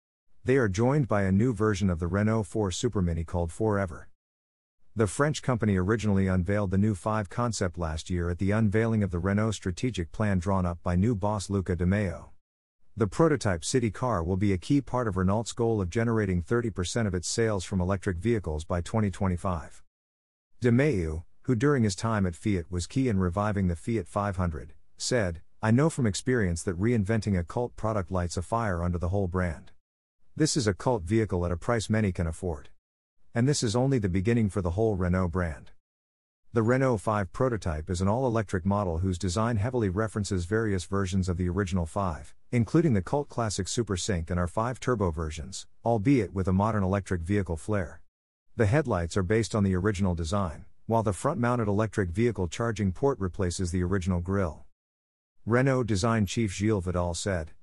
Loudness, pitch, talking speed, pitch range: -28 LUFS, 100 Hz, 190 wpm, 90-115 Hz